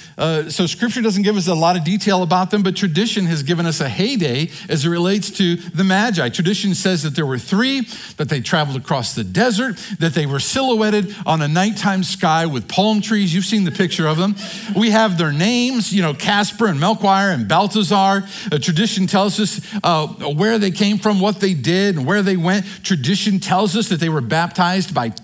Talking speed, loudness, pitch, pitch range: 210 wpm, -17 LUFS, 190 Hz, 170-205 Hz